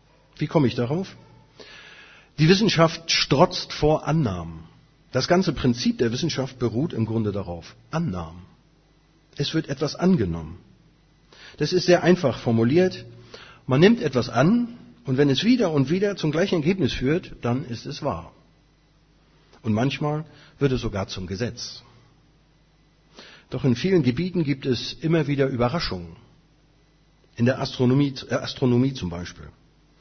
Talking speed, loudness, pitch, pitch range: 140 wpm, -23 LUFS, 140 Hz, 120-160 Hz